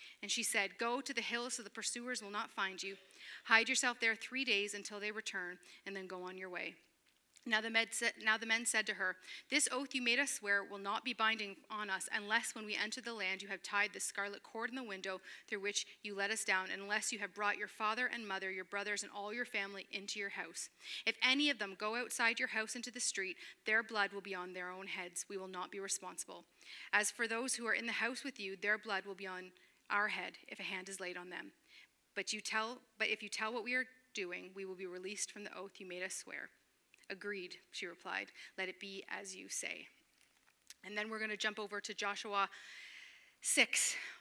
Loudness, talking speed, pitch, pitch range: -38 LUFS, 240 wpm, 205 Hz, 195-225 Hz